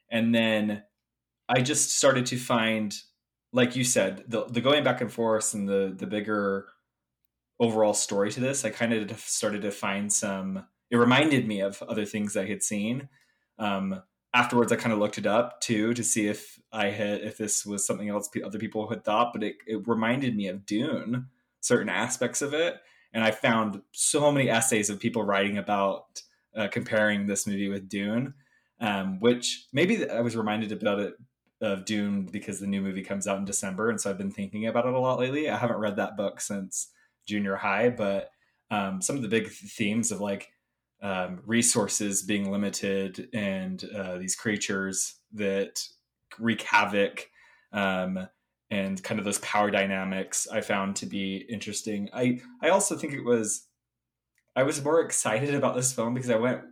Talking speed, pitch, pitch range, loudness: 185 wpm, 105 Hz, 100-115 Hz, -27 LUFS